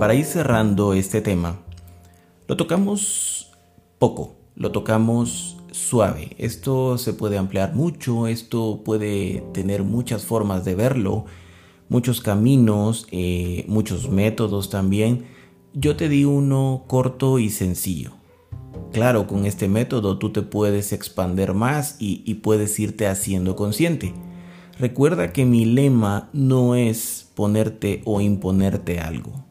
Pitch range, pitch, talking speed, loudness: 95-120 Hz, 105 Hz, 125 wpm, -21 LUFS